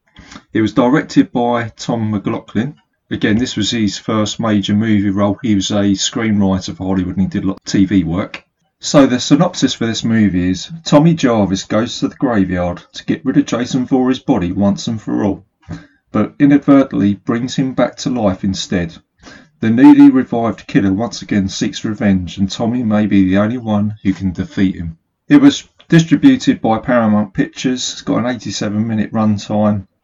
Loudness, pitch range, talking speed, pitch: -14 LUFS, 95-125 Hz, 180 wpm, 105 Hz